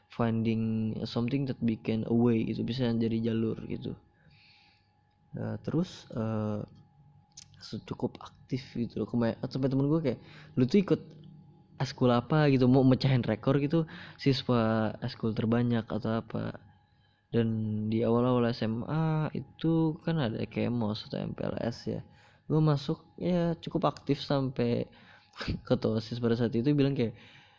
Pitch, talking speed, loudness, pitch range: 120 Hz, 135 wpm, -30 LUFS, 110-145 Hz